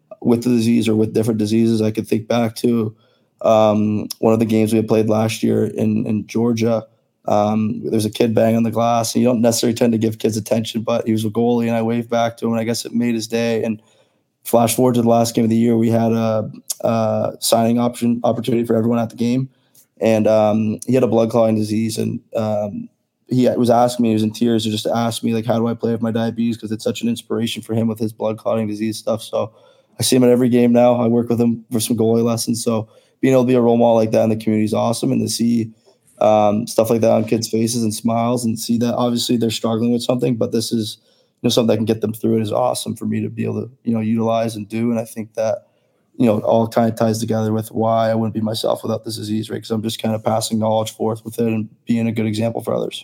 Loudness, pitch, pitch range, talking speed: -18 LUFS, 115 Hz, 110-115 Hz, 270 wpm